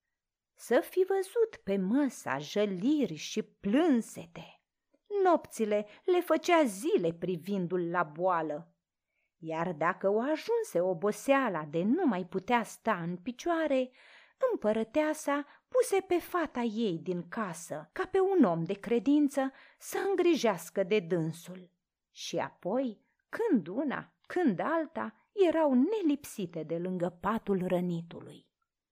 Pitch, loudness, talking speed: 230 Hz, -31 LUFS, 115 wpm